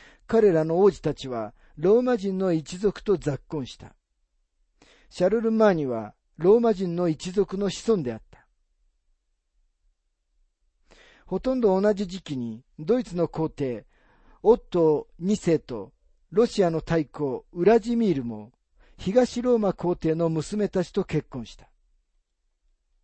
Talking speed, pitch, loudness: 235 characters per minute, 160 Hz, -24 LUFS